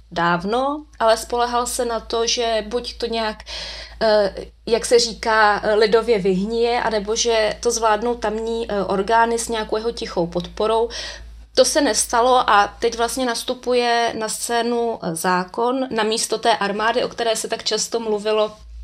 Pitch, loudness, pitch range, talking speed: 225 Hz, -20 LUFS, 215-235 Hz, 145 wpm